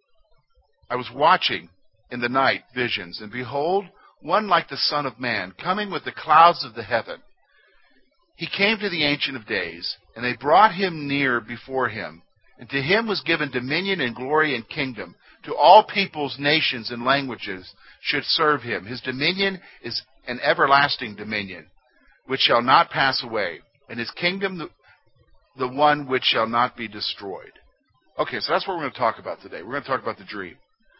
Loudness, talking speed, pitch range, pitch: -22 LUFS, 180 wpm, 120-165 Hz, 135 Hz